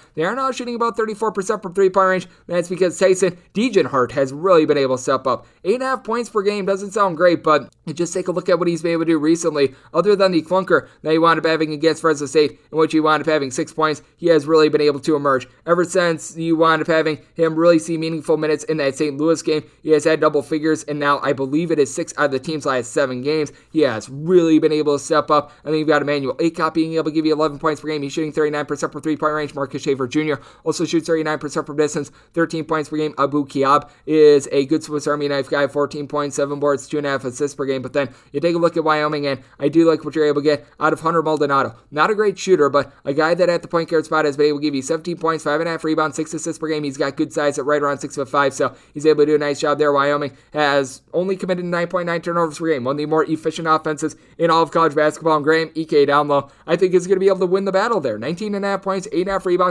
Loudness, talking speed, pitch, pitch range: -19 LUFS, 280 wpm, 155 Hz, 145-165 Hz